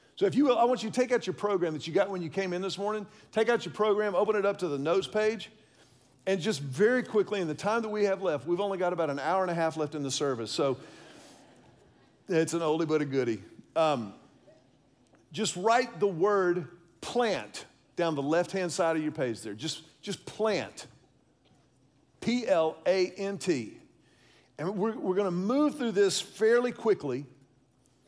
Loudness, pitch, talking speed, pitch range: -29 LUFS, 190 Hz, 205 wpm, 160-215 Hz